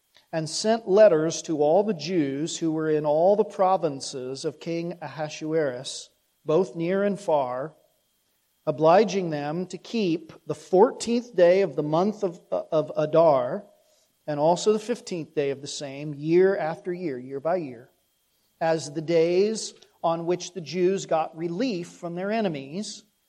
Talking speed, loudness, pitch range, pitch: 150 wpm, -25 LUFS, 155-195 Hz, 170 Hz